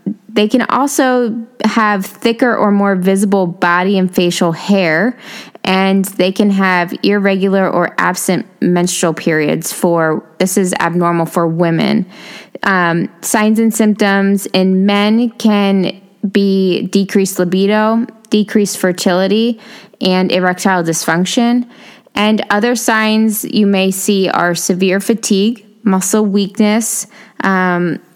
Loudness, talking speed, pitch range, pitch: -13 LUFS, 115 wpm, 185-220 Hz, 200 Hz